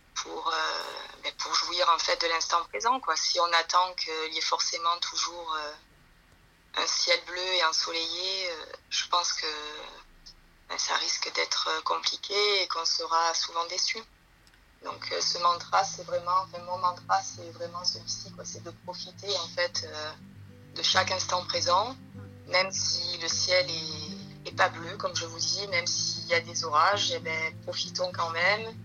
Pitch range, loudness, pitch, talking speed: 160-185 Hz, -28 LUFS, 170 Hz, 175 wpm